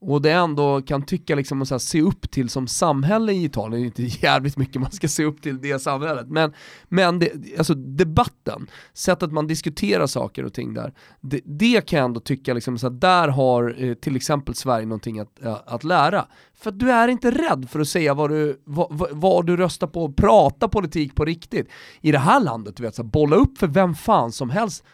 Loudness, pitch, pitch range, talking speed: -21 LUFS, 150 Hz, 130-180 Hz, 215 wpm